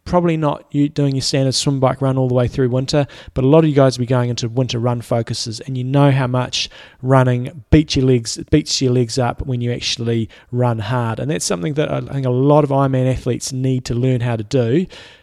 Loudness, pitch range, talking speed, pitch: -17 LUFS, 125-140 Hz, 250 wpm, 130 Hz